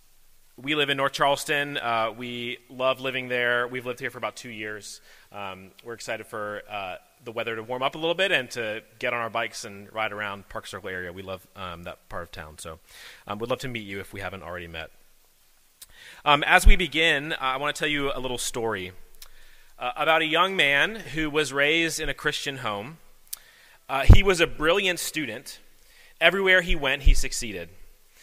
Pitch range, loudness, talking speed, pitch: 100-145 Hz, -25 LUFS, 205 wpm, 125 Hz